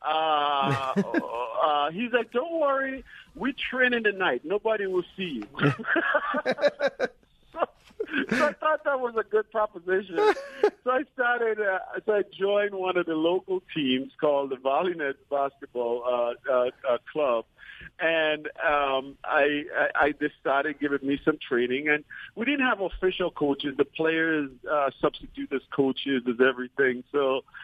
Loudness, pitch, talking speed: -26 LUFS, 170 Hz, 155 wpm